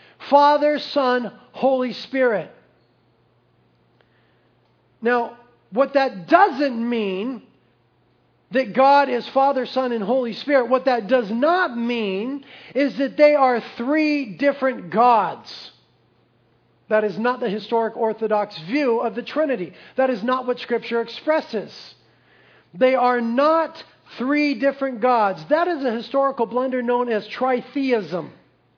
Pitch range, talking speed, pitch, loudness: 235-275 Hz, 125 wpm, 255 Hz, -20 LUFS